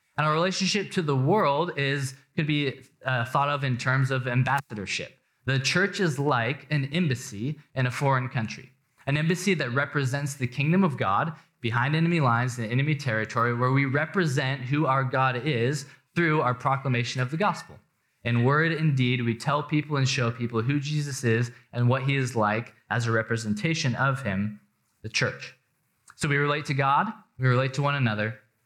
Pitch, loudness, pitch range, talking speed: 135 Hz, -26 LUFS, 125-150 Hz, 185 wpm